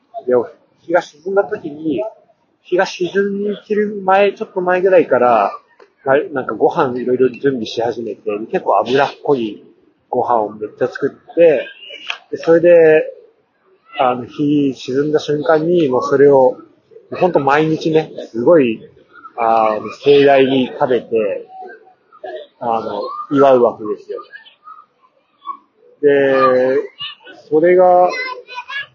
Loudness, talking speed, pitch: -15 LUFS, 220 characters per minute, 205 Hz